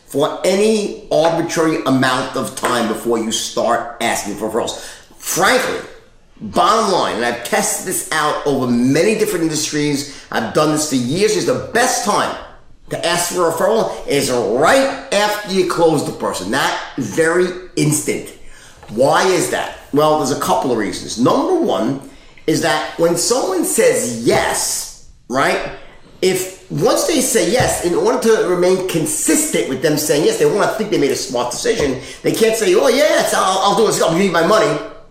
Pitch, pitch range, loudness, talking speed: 165 Hz, 145-215 Hz, -16 LUFS, 180 wpm